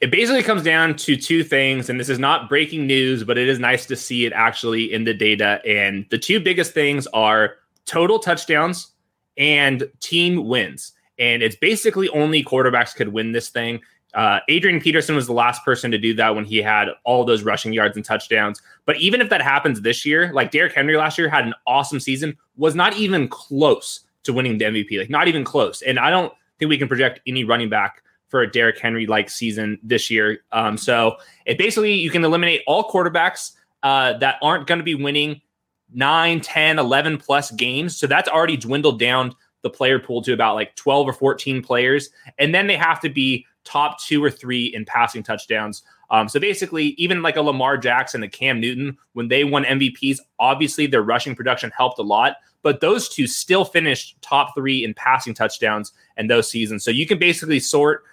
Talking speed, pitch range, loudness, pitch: 205 wpm, 115-155 Hz, -18 LUFS, 135 Hz